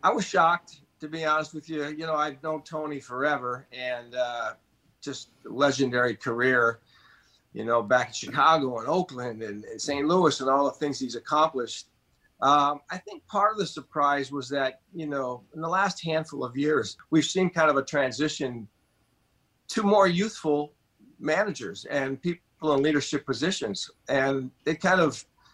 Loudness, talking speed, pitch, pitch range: -26 LUFS, 170 wpm, 145 Hz, 130-160 Hz